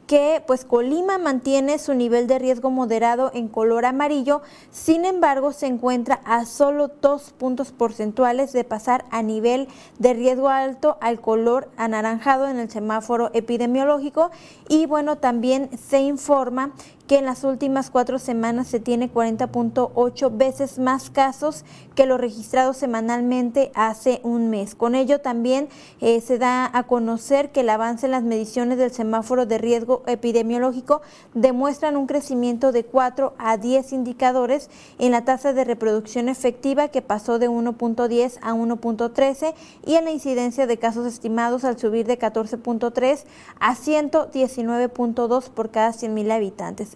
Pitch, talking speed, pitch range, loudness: 250 Hz, 145 wpm, 235-275 Hz, -21 LUFS